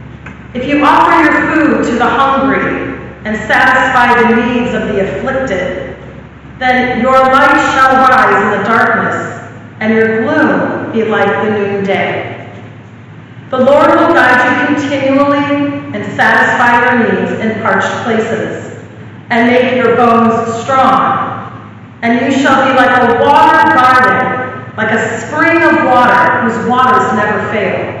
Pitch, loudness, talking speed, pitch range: 245 Hz, -9 LUFS, 140 wpm, 220-265 Hz